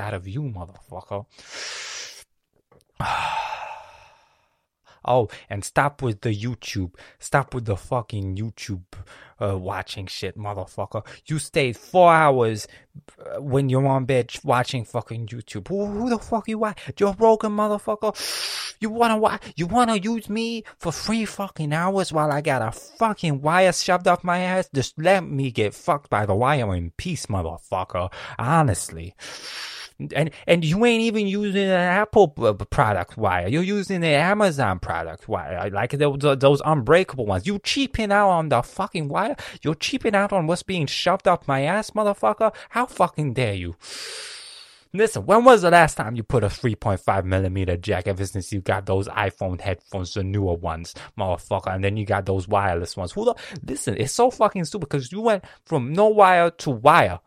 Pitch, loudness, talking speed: 140 Hz, -22 LUFS, 170 wpm